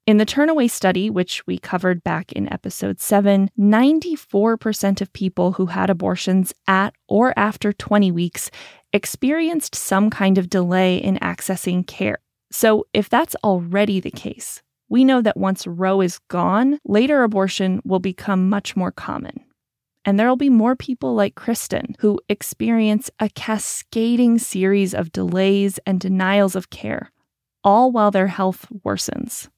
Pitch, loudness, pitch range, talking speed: 200 Hz, -19 LUFS, 190-220 Hz, 150 wpm